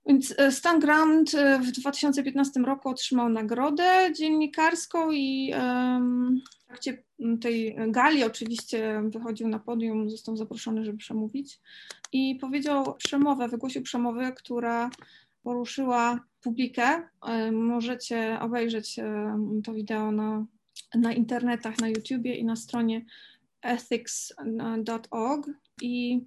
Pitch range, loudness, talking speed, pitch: 225-270 Hz, -27 LUFS, 100 wpm, 245 Hz